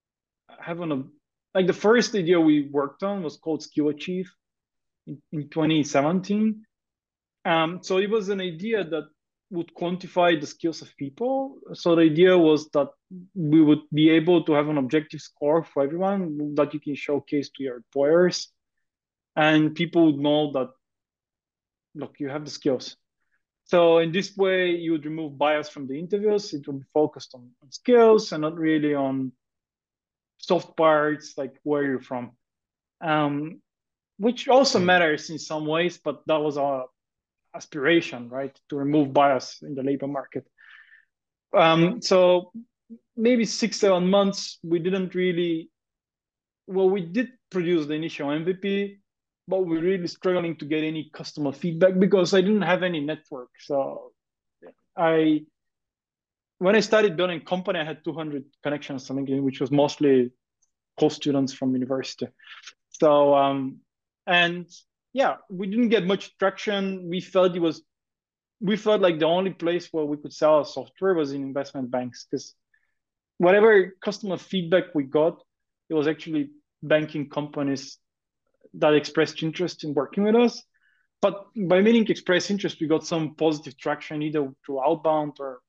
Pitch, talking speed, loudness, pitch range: 160 Hz, 155 wpm, -24 LUFS, 145-185 Hz